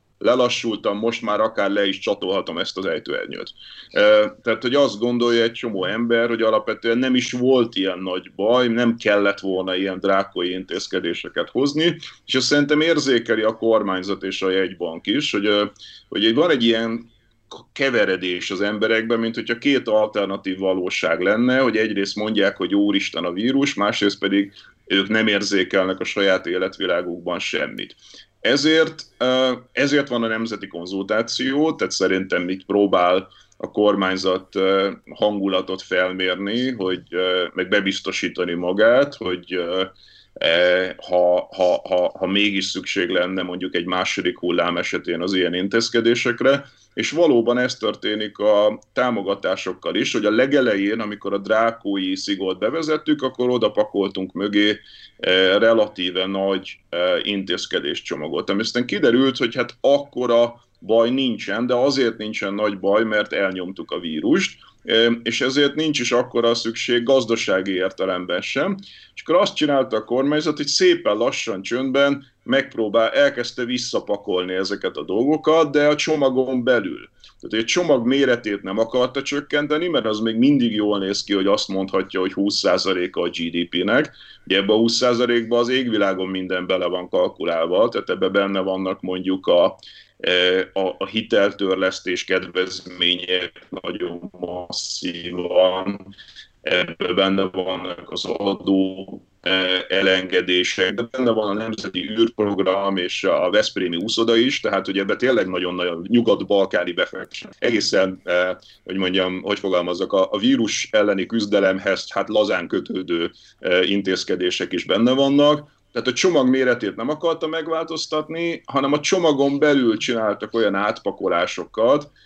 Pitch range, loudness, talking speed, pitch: 95-125 Hz, -20 LUFS, 135 wpm, 105 Hz